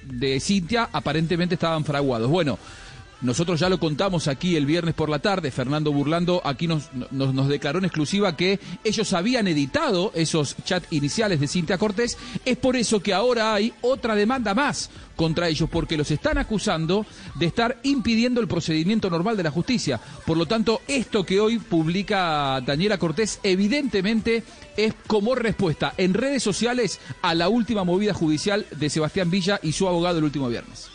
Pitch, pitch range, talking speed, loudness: 180 Hz, 155-215 Hz, 175 wpm, -23 LUFS